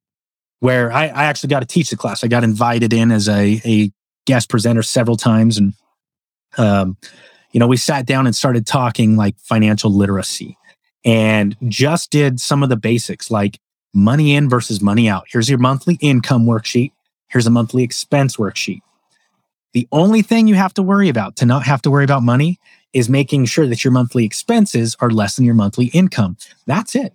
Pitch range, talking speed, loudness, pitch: 110-140 Hz, 190 wpm, -15 LUFS, 120 Hz